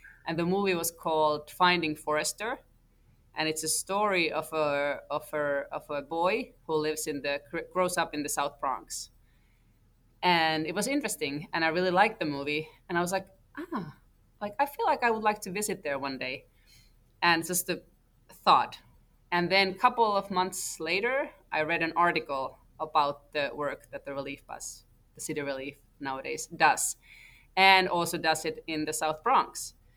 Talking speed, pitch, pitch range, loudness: 180 wpm, 160 Hz, 145-180 Hz, -29 LUFS